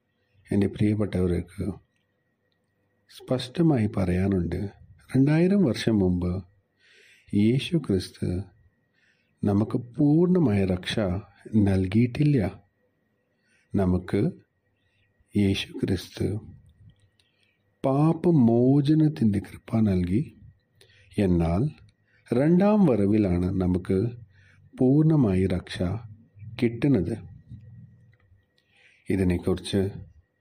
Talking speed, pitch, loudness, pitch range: 55 wpm, 100 Hz, -25 LUFS, 95-120 Hz